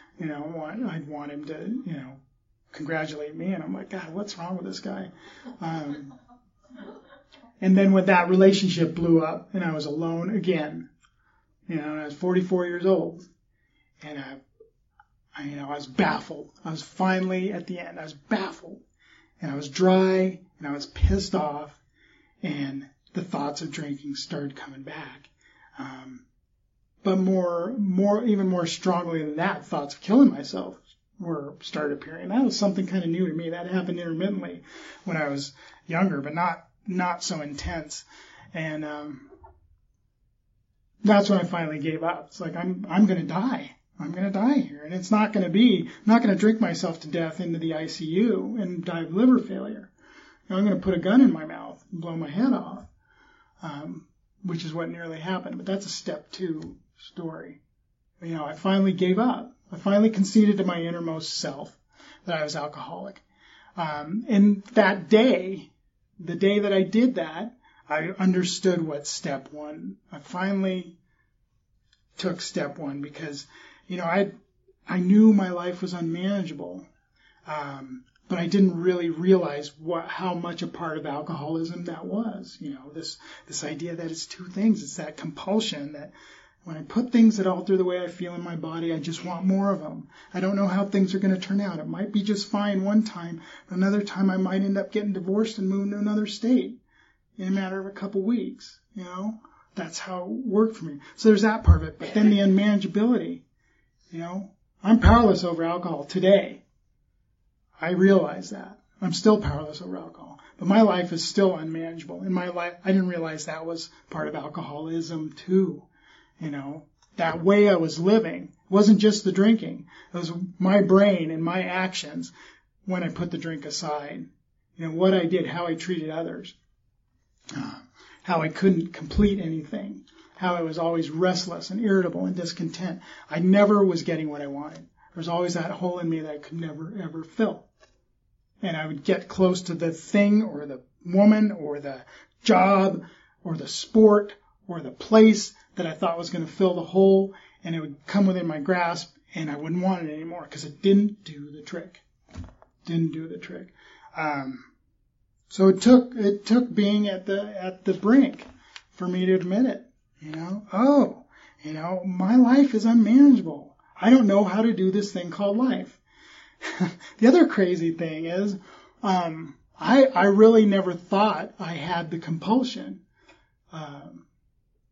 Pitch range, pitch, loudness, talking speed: 160-200 Hz, 180 Hz, -24 LUFS, 180 wpm